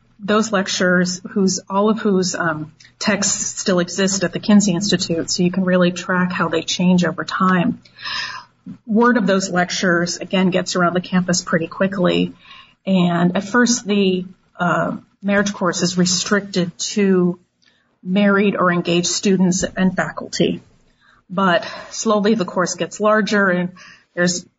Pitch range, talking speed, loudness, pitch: 175-200 Hz, 145 wpm, -18 LUFS, 185 Hz